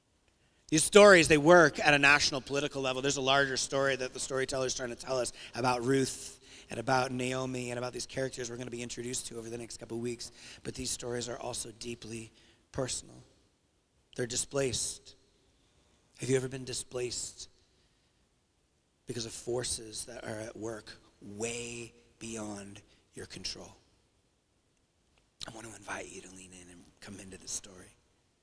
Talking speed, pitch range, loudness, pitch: 170 wpm, 115-130 Hz, -30 LUFS, 120 Hz